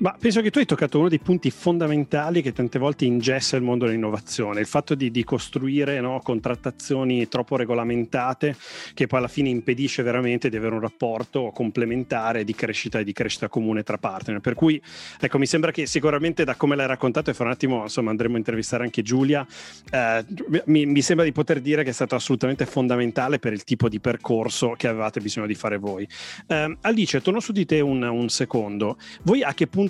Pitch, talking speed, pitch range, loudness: 130 Hz, 205 wpm, 115-150 Hz, -23 LUFS